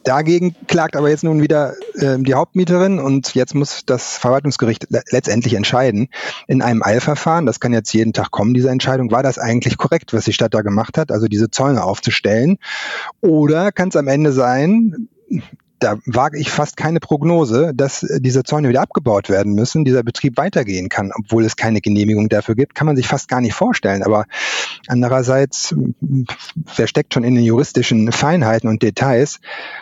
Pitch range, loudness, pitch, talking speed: 115-155 Hz, -16 LUFS, 130 Hz, 175 wpm